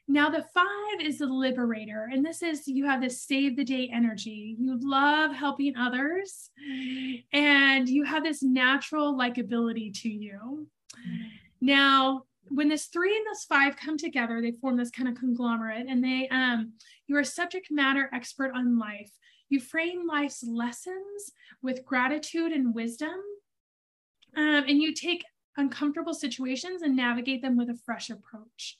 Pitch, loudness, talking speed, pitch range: 270 Hz, -27 LUFS, 155 wpm, 245-300 Hz